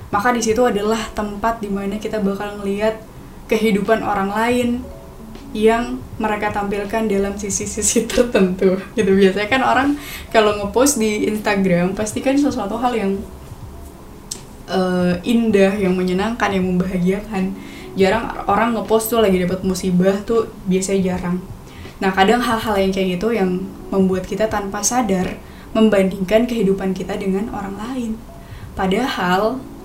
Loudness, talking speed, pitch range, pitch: -18 LUFS, 130 wpm, 195-225 Hz, 205 Hz